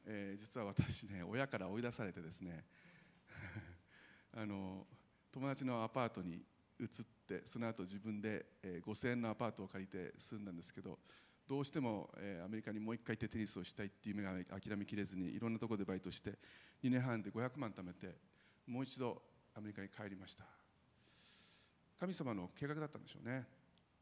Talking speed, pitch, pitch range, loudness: 330 characters per minute, 105 Hz, 95-120 Hz, -46 LUFS